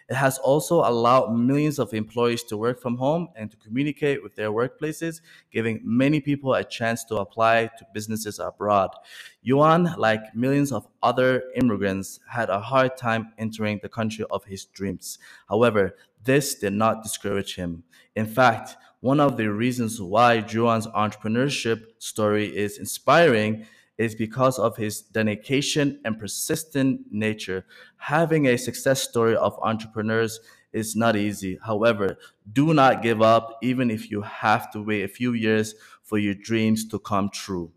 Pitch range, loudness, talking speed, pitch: 105-130 Hz, -23 LUFS, 155 wpm, 115 Hz